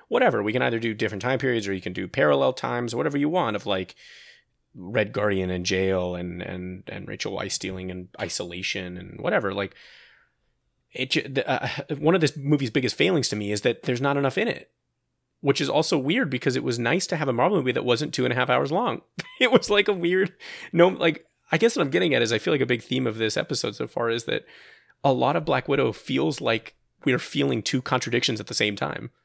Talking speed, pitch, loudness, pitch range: 235 wpm, 120 Hz, -24 LUFS, 95-145 Hz